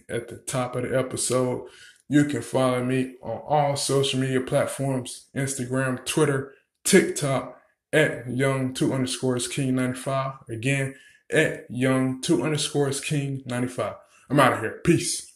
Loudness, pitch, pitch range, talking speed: -25 LUFS, 130 Hz, 125-140 Hz, 130 wpm